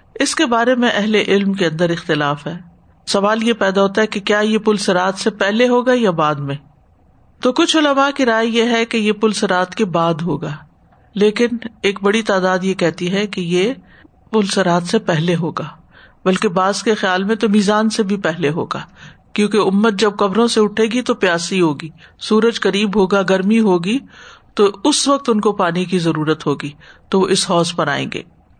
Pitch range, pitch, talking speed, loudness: 175-225 Hz, 200 Hz, 200 wpm, -16 LUFS